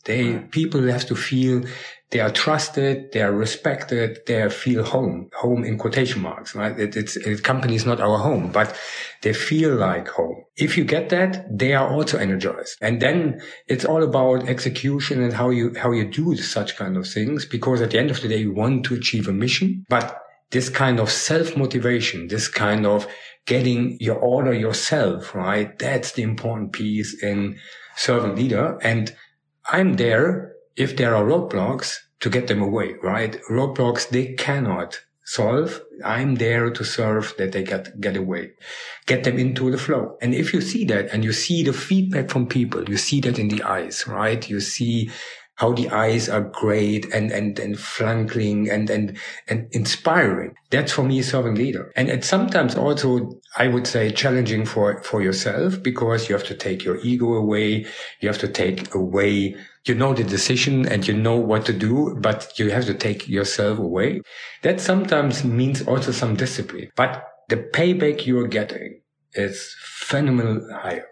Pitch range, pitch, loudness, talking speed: 105-130 Hz, 120 Hz, -21 LUFS, 180 wpm